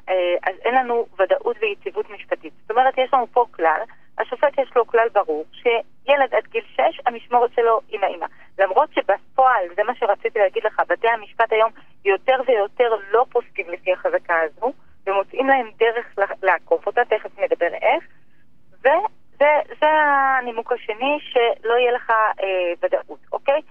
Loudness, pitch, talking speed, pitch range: -20 LUFS, 230 Hz, 150 wpm, 195-260 Hz